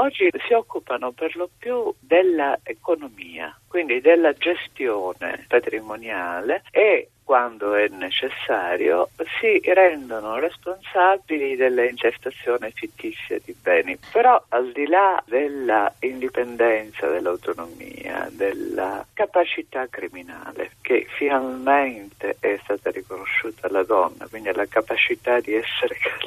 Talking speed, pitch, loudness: 100 wpm, 180 Hz, -22 LUFS